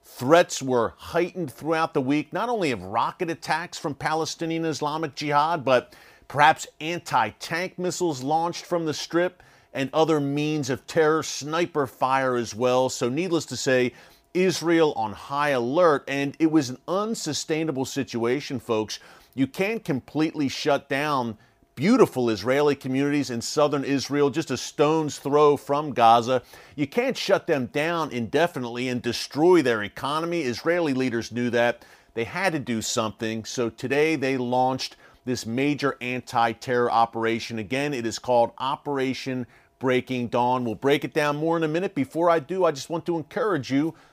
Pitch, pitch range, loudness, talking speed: 140 Hz, 125-160 Hz, -24 LUFS, 160 wpm